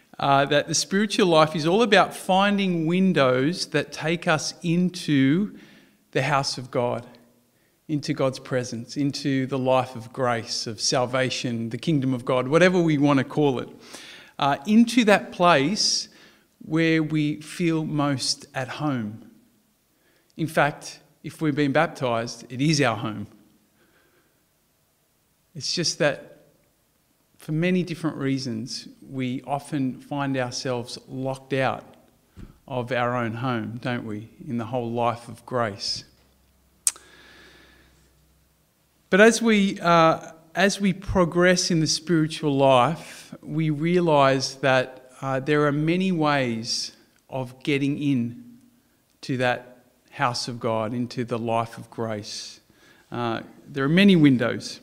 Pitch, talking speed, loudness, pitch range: 140 Hz, 130 wpm, -23 LUFS, 125-160 Hz